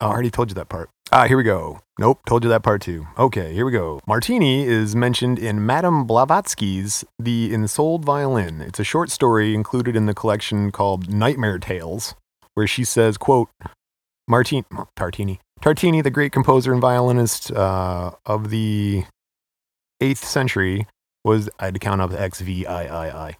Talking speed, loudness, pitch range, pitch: 175 wpm, -20 LUFS, 95-125 Hz, 110 Hz